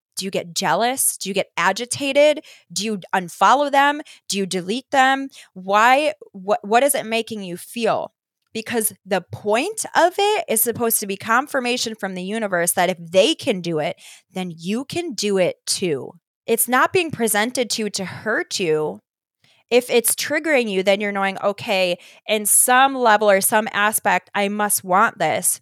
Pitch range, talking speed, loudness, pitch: 190-255 Hz, 180 wpm, -19 LUFS, 215 Hz